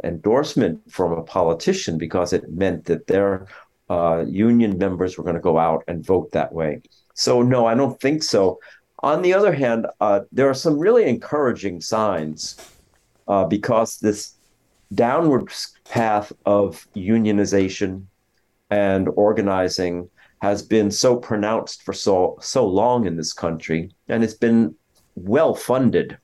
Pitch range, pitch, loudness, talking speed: 95-115 Hz, 105 Hz, -20 LUFS, 145 wpm